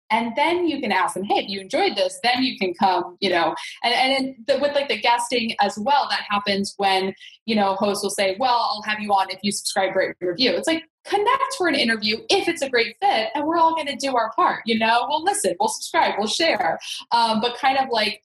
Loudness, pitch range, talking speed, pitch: -21 LUFS, 200-300 Hz, 250 wpm, 240 Hz